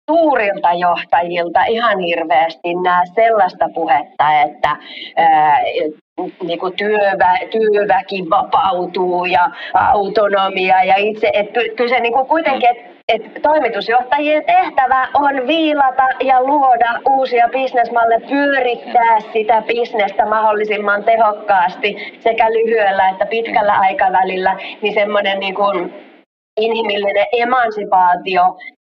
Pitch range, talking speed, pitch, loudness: 190-245 Hz, 100 wpm, 215 Hz, -14 LUFS